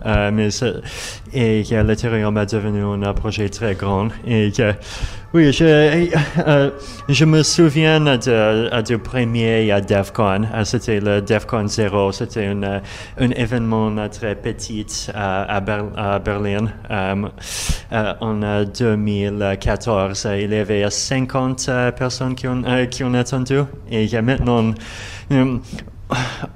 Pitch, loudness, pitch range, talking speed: 110 Hz, -18 LUFS, 105-125 Hz, 150 wpm